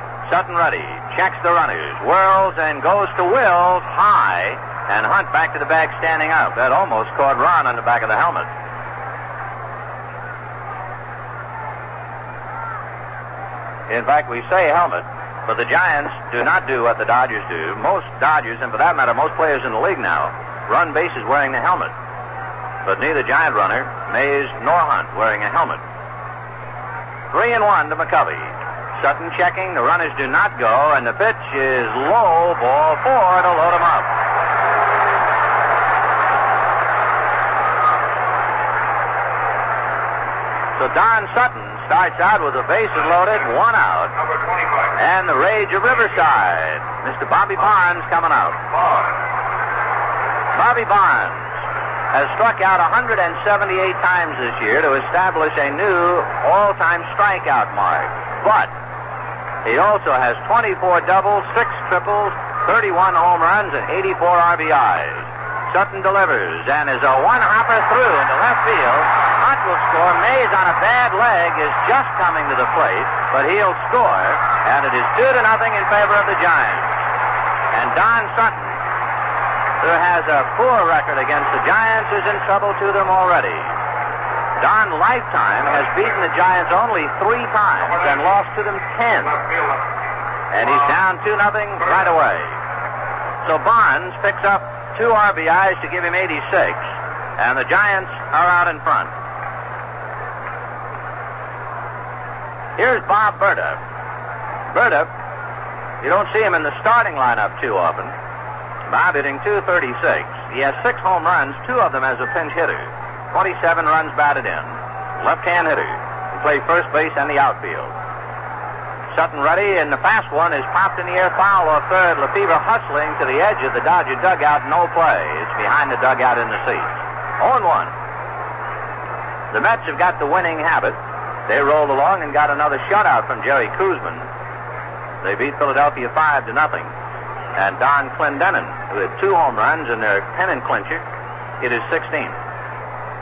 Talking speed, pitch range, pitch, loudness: 150 wpm, 145-195 Hz, 175 Hz, -16 LUFS